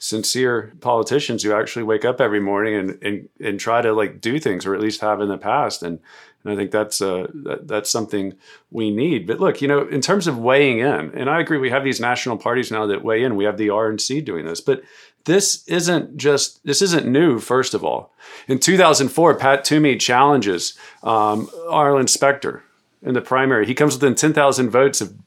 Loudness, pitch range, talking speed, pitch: -18 LUFS, 105-140 Hz, 215 wpm, 125 Hz